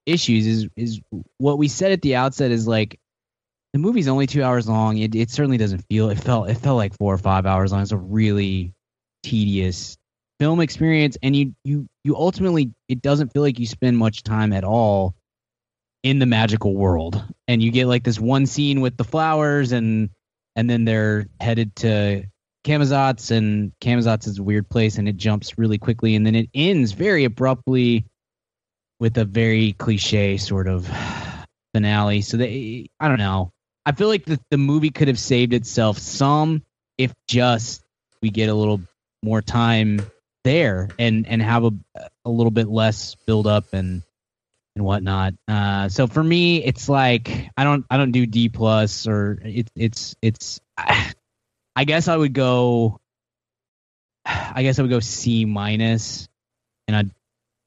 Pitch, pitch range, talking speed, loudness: 115 Hz, 105-130 Hz, 175 wpm, -20 LUFS